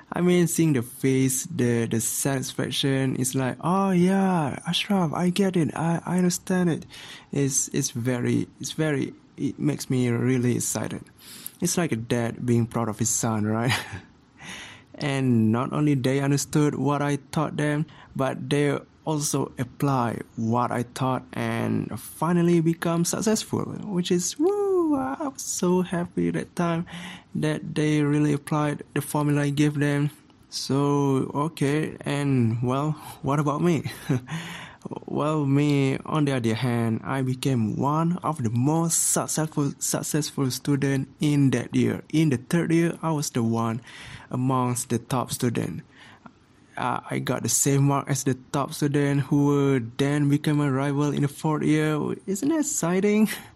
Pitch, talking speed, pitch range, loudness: 145 Hz, 155 wpm, 130-165 Hz, -25 LUFS